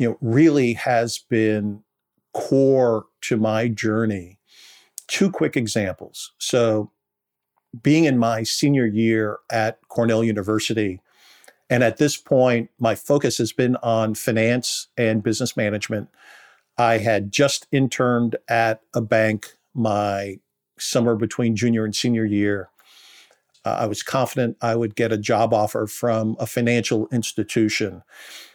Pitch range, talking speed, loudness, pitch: 110-120 Hz, 130 wpm, -21 LUFS, 115 Hz